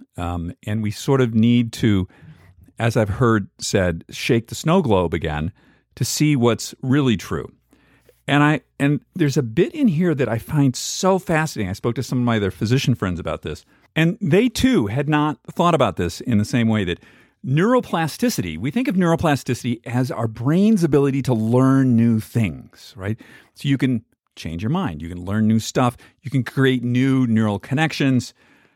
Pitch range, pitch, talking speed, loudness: 110-145 Hz, 125 Hz, 185 wpm, -20 LUFS